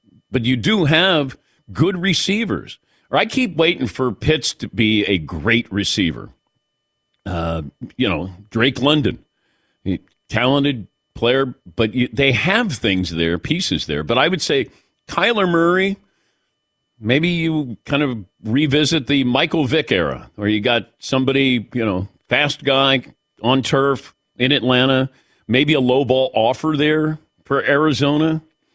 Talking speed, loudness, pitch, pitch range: 140 wpm, -18 LUFS, 135 Hz, 115-150 Hz